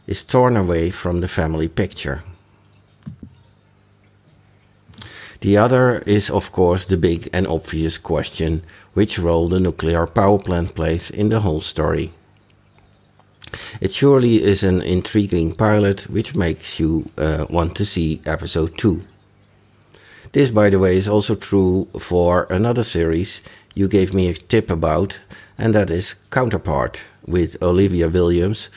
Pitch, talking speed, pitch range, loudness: 95 Hz, 140 wpm, 85-105 Hz, -18 LUFS